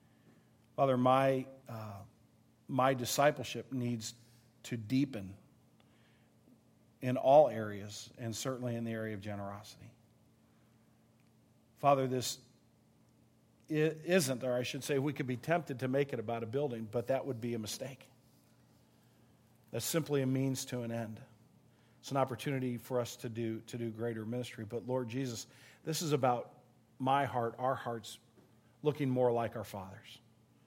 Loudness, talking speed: -35 LUFS, 145 wpm